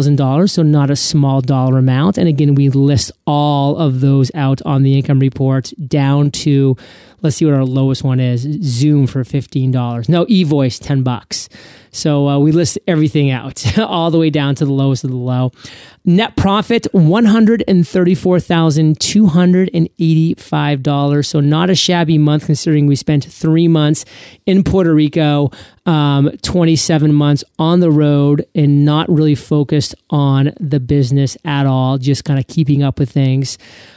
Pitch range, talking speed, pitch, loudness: 135-160 Hz, 155 wpm, 145 Hz, -13 LUFS